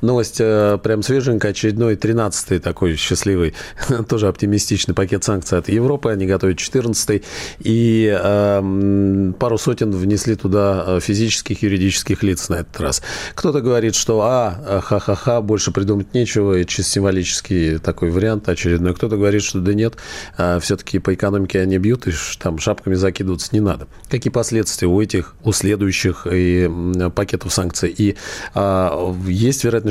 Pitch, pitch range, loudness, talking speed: 100 Hz, 95-110 Hz, -18 LUFS, 140 wpm